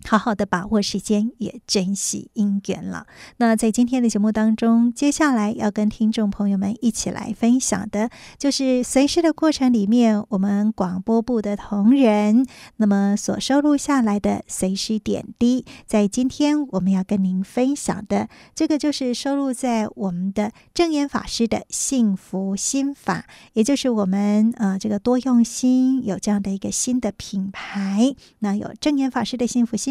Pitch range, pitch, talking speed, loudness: 205-255 Hz, 225 Hz, 255 characters per minute, -21 LUFS